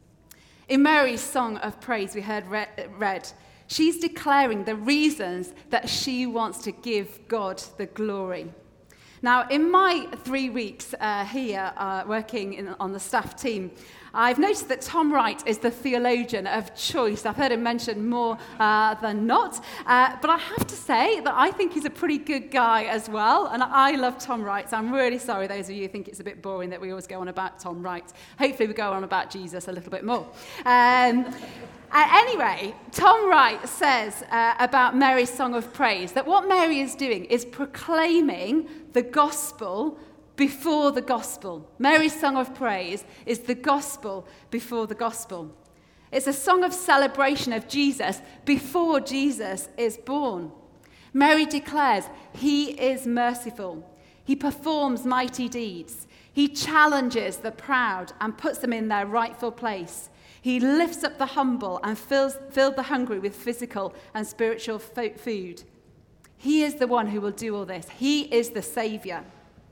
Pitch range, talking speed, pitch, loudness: 210-280 Hz, 170 wpm, 240 Hz, -24 LUFS